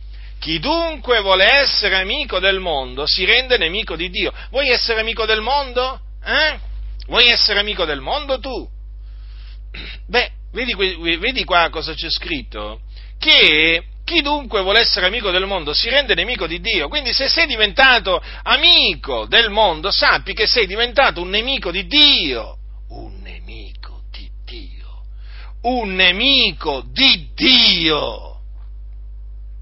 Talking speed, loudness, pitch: 135 wpm, -15 LUFS, 195 Hz